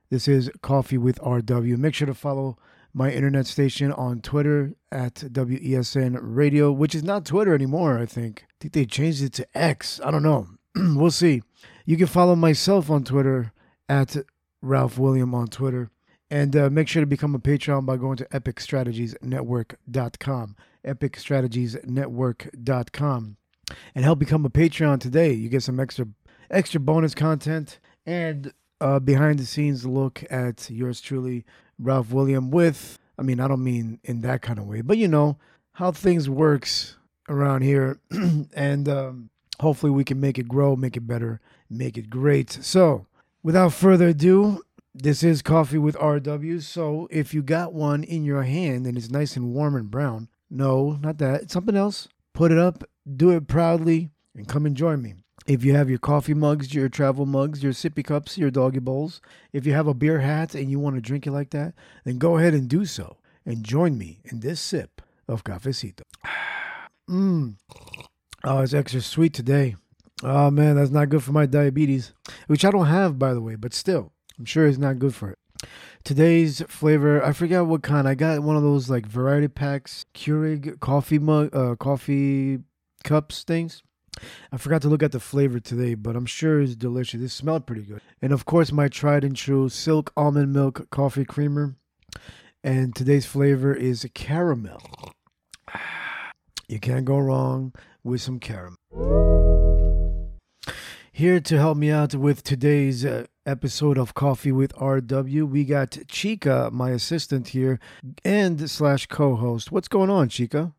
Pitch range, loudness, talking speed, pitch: 130-155 Hz, -23 LUFS, 170 wpm, 140 Hz